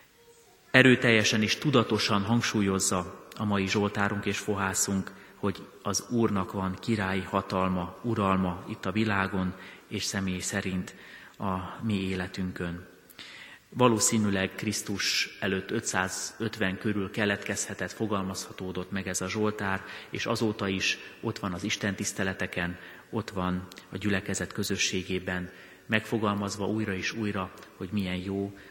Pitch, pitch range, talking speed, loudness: 100 Hz, 95-105 Hz, 115 wpm, -29 LUFS